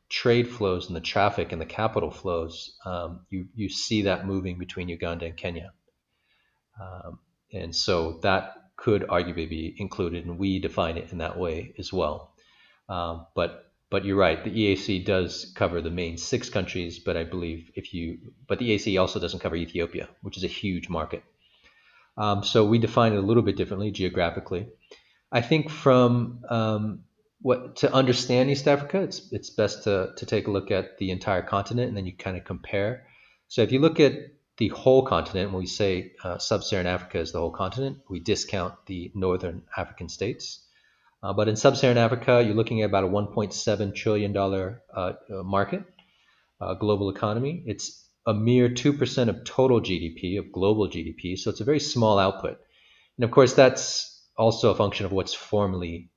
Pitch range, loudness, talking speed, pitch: 90-115 Hz, -26 LUFS, 185 wpm, 100 Hz